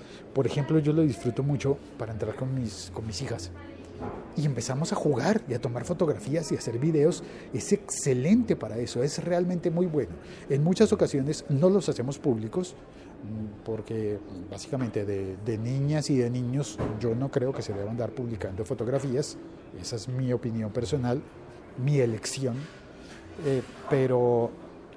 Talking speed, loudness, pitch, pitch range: 160 wpm, -28 LUFS, 130 Hz, 115-150 Hz